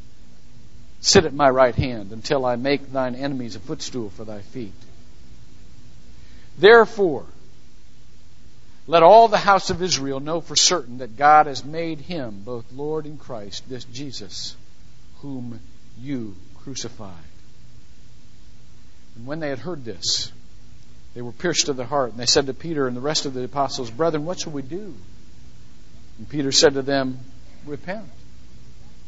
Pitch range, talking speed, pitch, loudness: 115-150 Hz, 150 wpm, 130 Hz, -20 LUFS